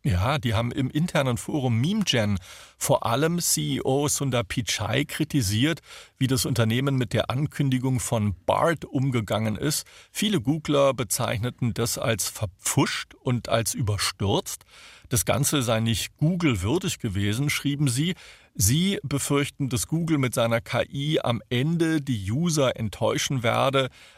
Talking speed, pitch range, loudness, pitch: 130 wpm, 115-145 Hz, -25 LUFS, 130 Hz